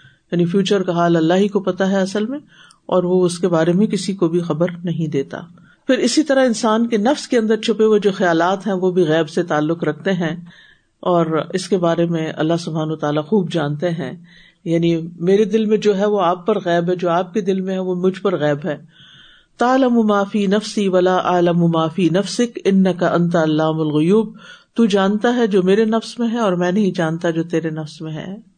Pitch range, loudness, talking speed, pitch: 170-205 Hz, -17 LUFS, 220 wpm, 180 Hz